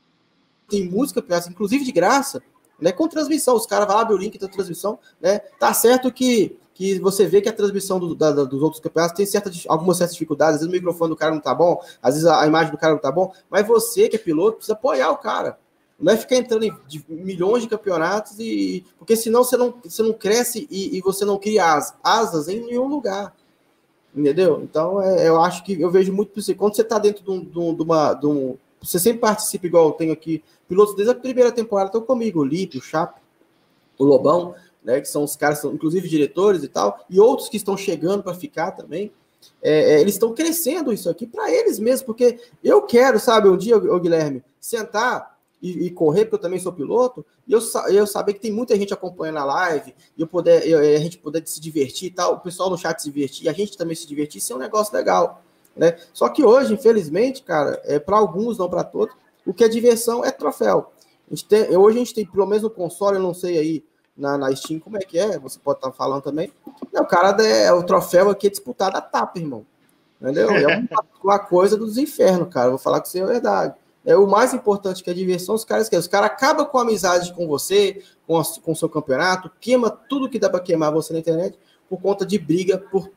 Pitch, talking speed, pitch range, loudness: 195 Hz, 230 wpm, 165-230 Hz, -19 LUFS